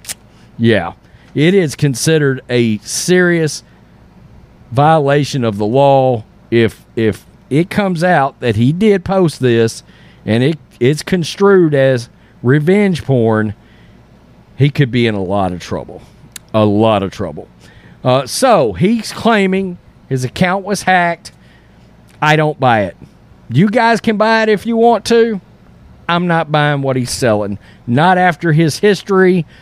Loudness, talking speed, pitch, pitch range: -13 LUFS, 140 wpm, 140 Hz, 115-180 Hz